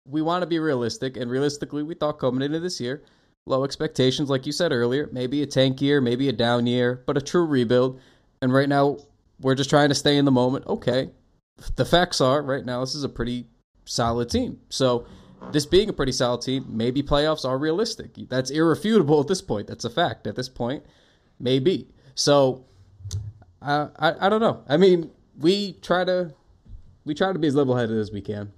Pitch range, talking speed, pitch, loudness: 125-155 Hz, 205 wpm, 135 Hz, -23 LUFS